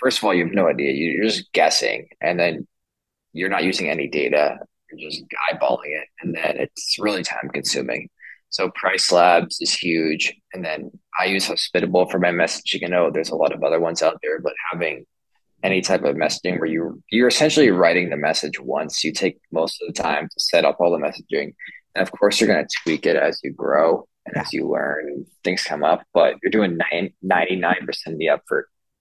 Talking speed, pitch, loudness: 215 wpm, 100 Hz, -20 LUFS